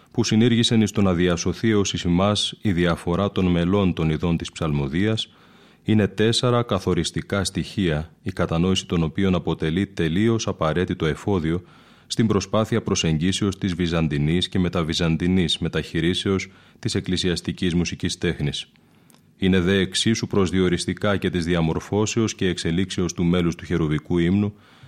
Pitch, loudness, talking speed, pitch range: 90 Hz, -22 LUFS, 130 wpm, 85-100 Hz